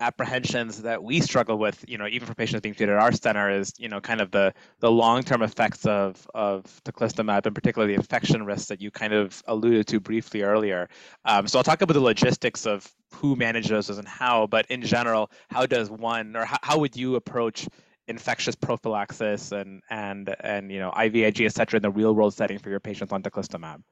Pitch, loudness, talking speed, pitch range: 110 Hz, -25 LUFS, 210 wpm, 100-115 Hz